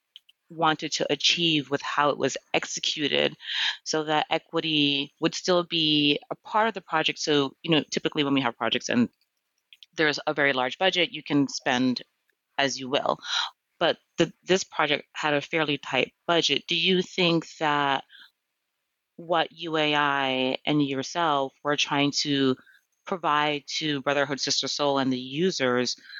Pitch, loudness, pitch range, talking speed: 150 Hz, -25 LUFS, 140-165 Hz, 155 wpm